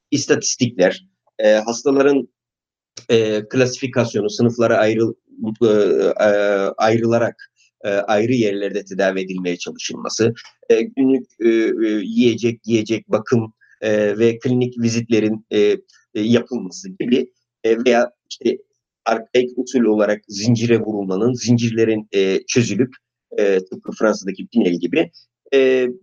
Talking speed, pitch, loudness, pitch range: 100 wpm, 115 Hz, -18 LUFS, 105-125 Hz